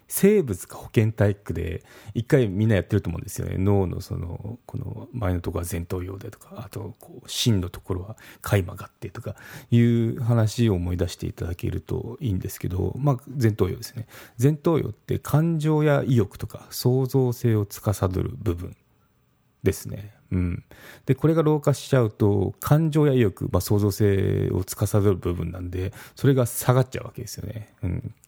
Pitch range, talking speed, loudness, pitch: 95-125 Hz, 345 characters per minute, -24 LUFS, 110 Hz